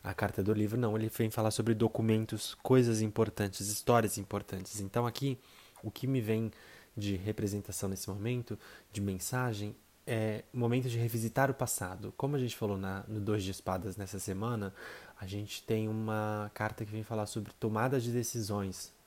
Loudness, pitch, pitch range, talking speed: -34 LUFS, 110 Hz, 100-115 Hz, 175 wpm